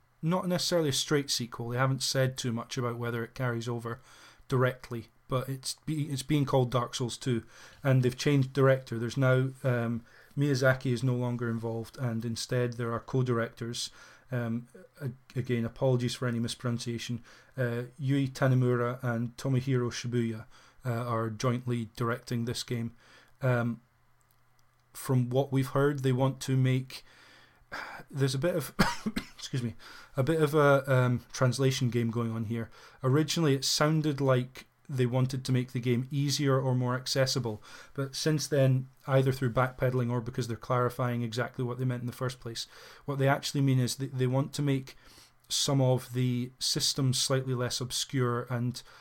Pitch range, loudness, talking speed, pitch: 120-135 Hz, -30 LUFS, 165 wpm, 125 Hz